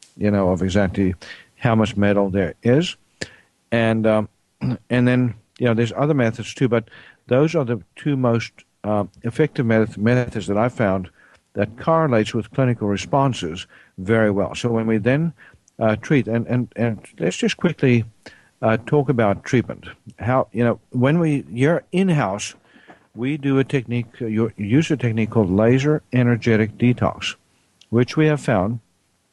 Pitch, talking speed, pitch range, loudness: 115 Hz, 160 wpm, 105-130 Hz, -20 LUFS